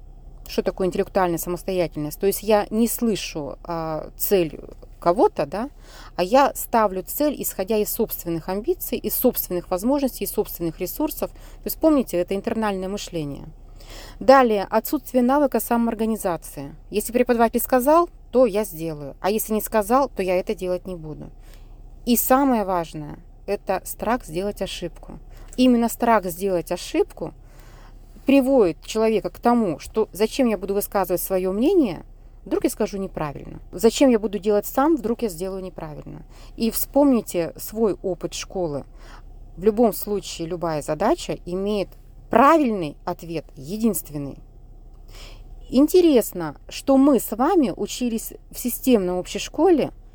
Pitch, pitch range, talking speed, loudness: 200 Hz, 170-235 Hz, 135 wpm, -22 LUFS